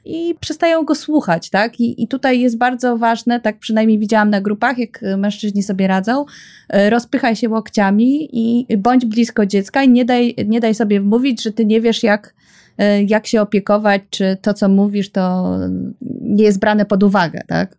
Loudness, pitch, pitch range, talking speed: -15 LUFS, 220 Hz, 205-240 Hz, 180 wpm